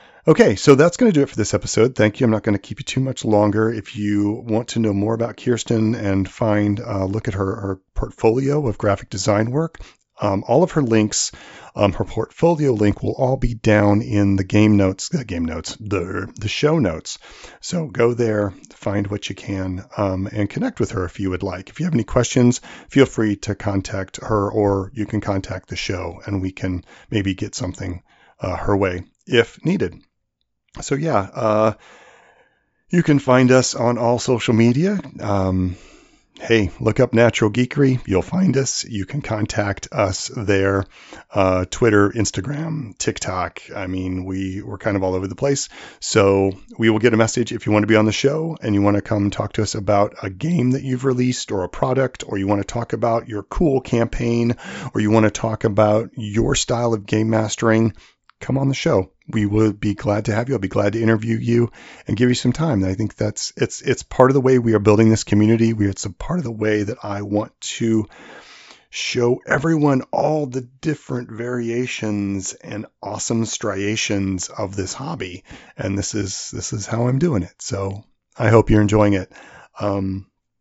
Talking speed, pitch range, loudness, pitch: 205 wpm, 100-125 Hz, -20 LUFS, 110 Hz